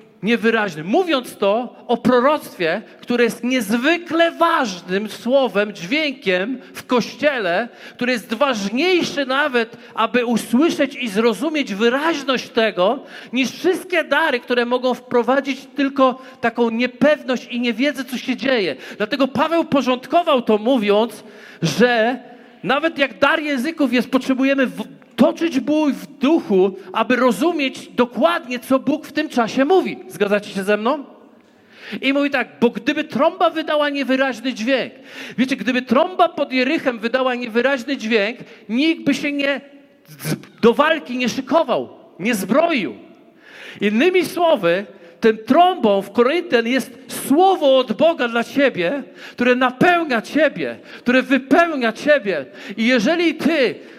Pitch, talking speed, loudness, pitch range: 255 Hz, 125 wpm, -18 LUFS, 235-290 Hz